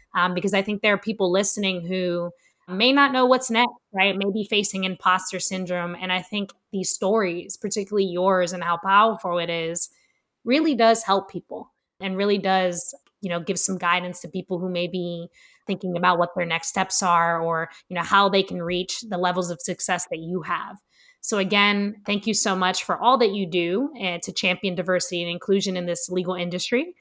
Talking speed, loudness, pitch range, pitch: 200 wpm, -23 LUFS, 180-205 Hz, 185 Hz